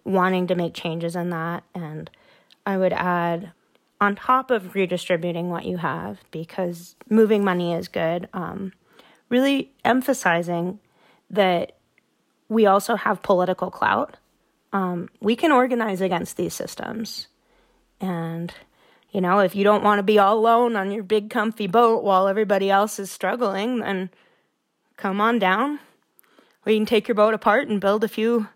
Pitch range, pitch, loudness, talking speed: 180-220 Hz, 200 Hz, -22 LUFS, 155 wpm